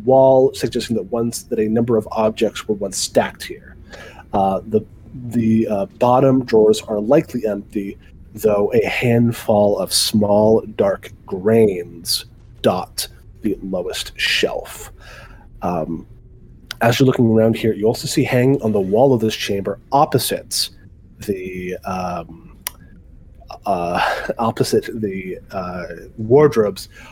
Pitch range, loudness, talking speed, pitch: 95-120 Hz, -18 LUFS, 125 wpm, 110 Hz